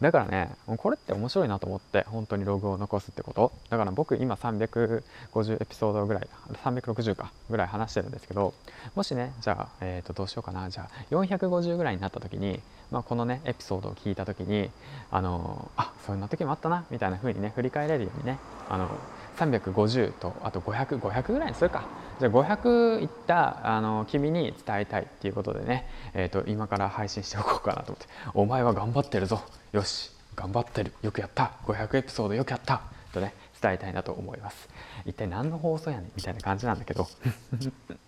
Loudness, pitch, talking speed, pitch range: -30 LUFS, 110 Hz, 385 characters per minute, 100-130 Hz